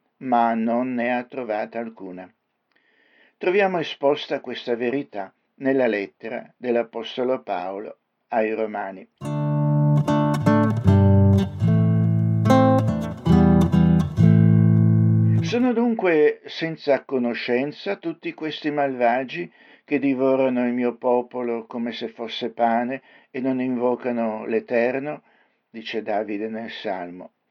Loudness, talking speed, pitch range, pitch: -21 LUFS, 85 wpm, 110-135 Hz, 120 Hz